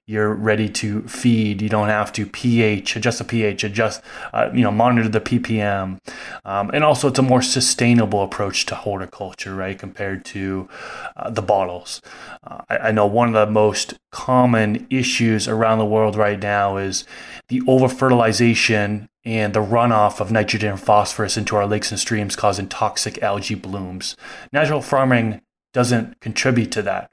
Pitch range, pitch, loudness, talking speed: 105-120 Hz, 110 Hz, -19 LUFS, 165 wpm